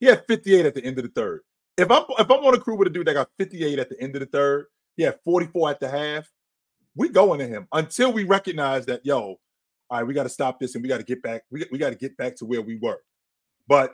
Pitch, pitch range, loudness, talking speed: 145 Hz, 130-195 Hz, -23 LUFS, 290 wpm